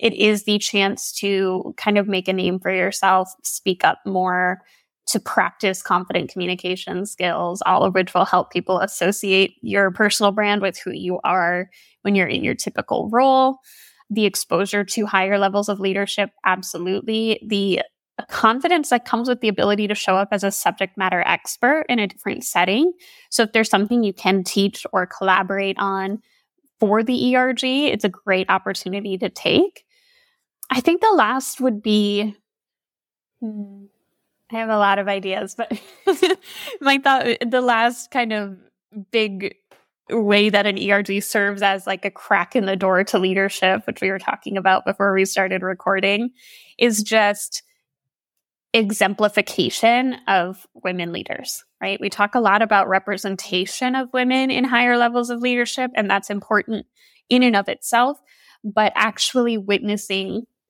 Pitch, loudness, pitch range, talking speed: 205 Hz, -19 LUFS, 195-235 Hz, 155 wpm